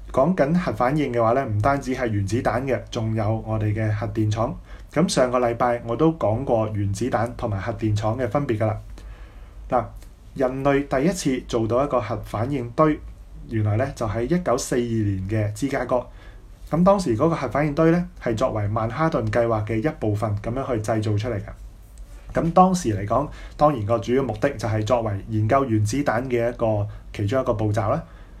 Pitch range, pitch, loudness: 110-135 Hz, 115 Hz, -23 LUFS